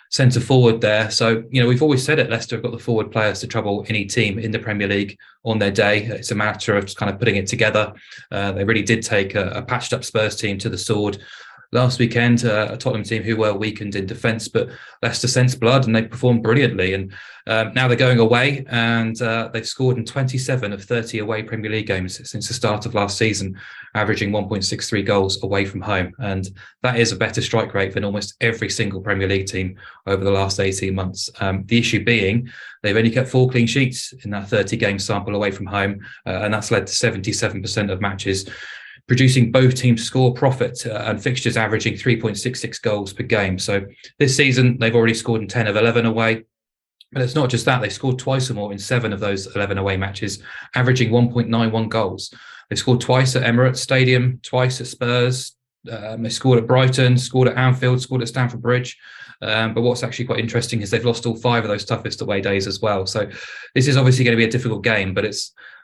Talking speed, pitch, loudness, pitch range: 220 wpm, 115 Hz, -19 LUFS, 105-125 Hz